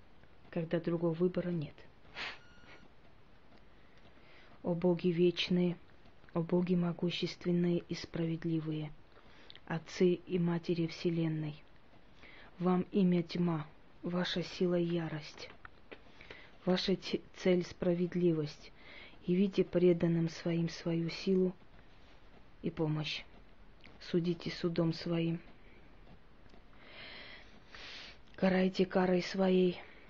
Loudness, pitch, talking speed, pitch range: -34 LUFS, 175 Hz, 75 wpm, 165-180 Hz